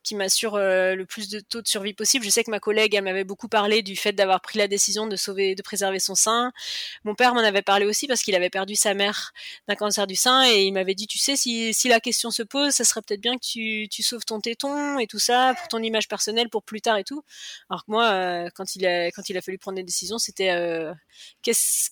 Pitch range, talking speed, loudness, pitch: 195-230 Hz, 270 wpm, -22 LUFS, 210 Hz